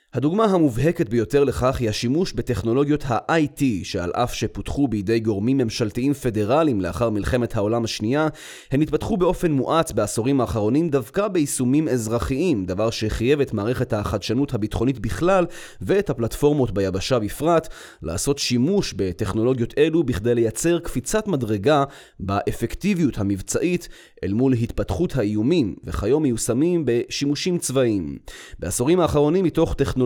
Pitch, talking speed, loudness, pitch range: 125 Hz, 120 wpm, -22 LUFS, 110-150 Hz